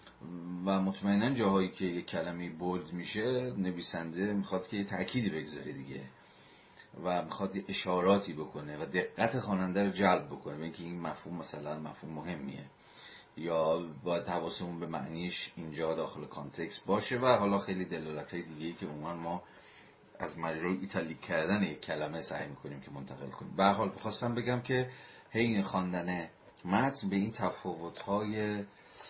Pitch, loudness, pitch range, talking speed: 90 Hz, -35 LUFS, 80-100 Hz, 155 wpm